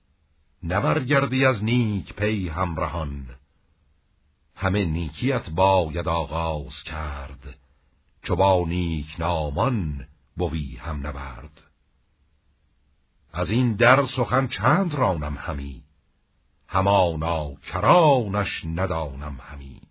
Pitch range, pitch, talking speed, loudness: 70-95 Hz, 80 Hz, 85 wpm, -23 LUFS